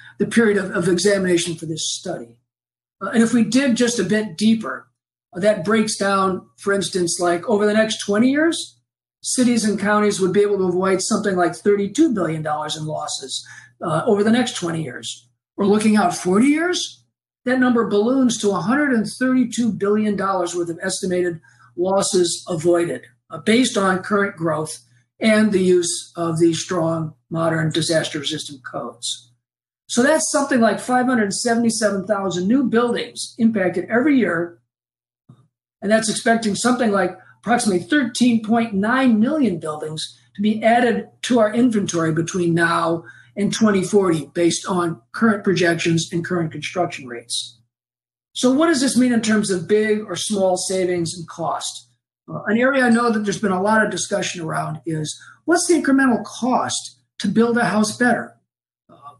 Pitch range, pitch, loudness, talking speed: 165-225 Hz, 195 Hz, -19 LUFS, 155 wpm